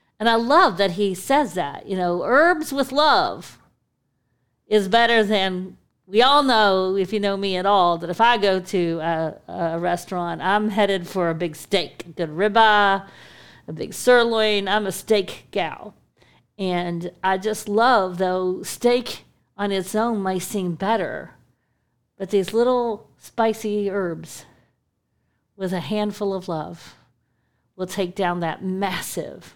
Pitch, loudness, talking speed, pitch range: 195 Hz, -21 LUFS, 150 wpm, 175-215 Hz